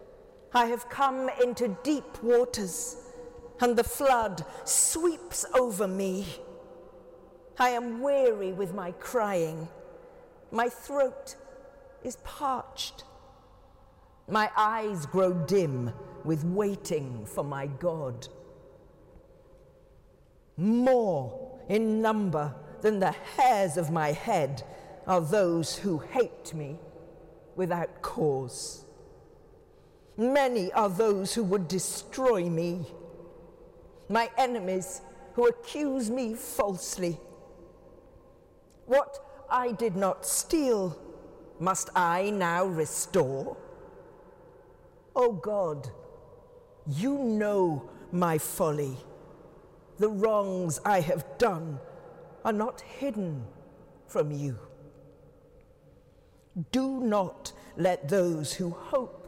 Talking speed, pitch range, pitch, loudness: 95 wpm, 175-255 Hz, 210 Hz, -29 LUFS